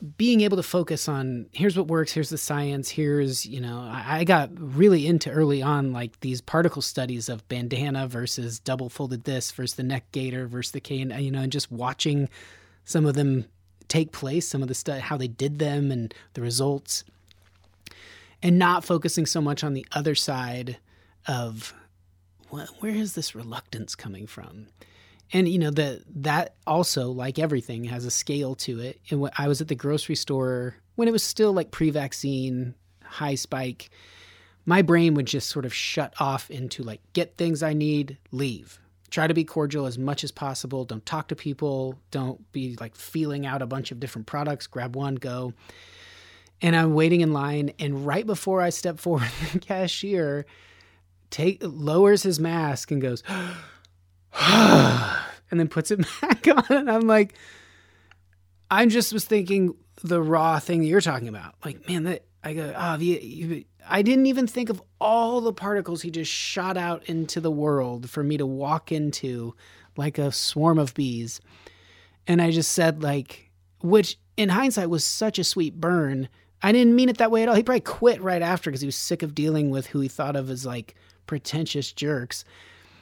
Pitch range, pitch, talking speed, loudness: 125-165 Hz, 145 Hz, 190 wpm, -24 LUFS